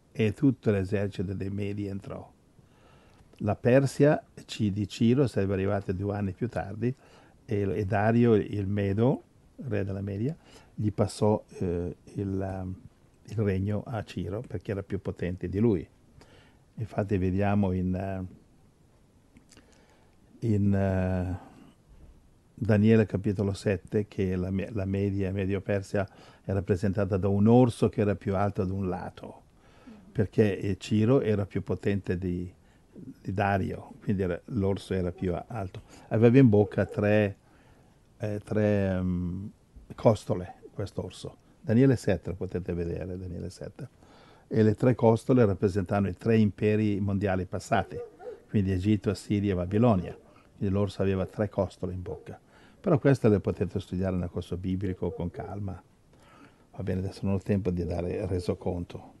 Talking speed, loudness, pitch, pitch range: 135 wpm, -28 LUFS, 100 Hz, 95-110 Hz